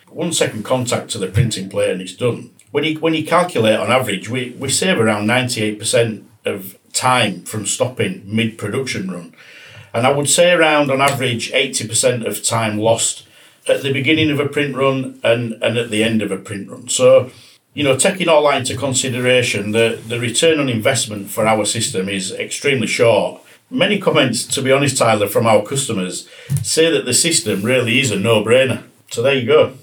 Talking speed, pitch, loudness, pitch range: 195 wpm, 125 Hz, -16 LUFS, 110-140 Hz